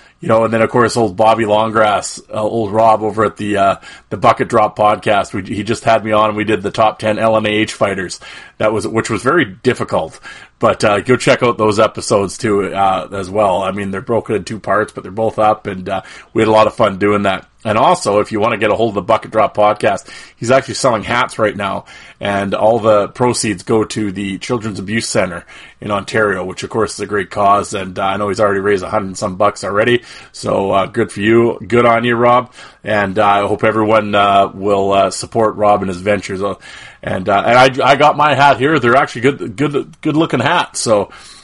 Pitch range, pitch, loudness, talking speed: 100-115 Hz, 110 Hz, -14 LUFS, 235 wpm